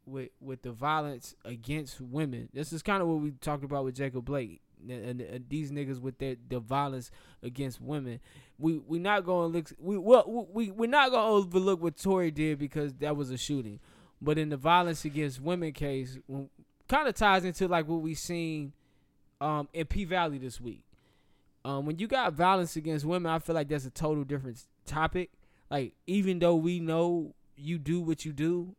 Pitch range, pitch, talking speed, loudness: 135-170 Hz, 150 Hz, 195 wpm, -31 LUFS